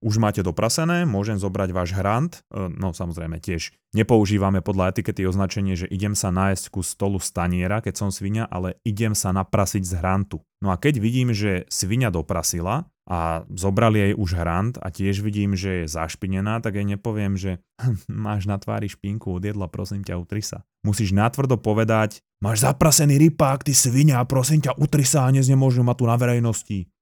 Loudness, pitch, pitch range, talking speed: -22 LUFS, 100 Hz, 95-115 Hz, 175 wpm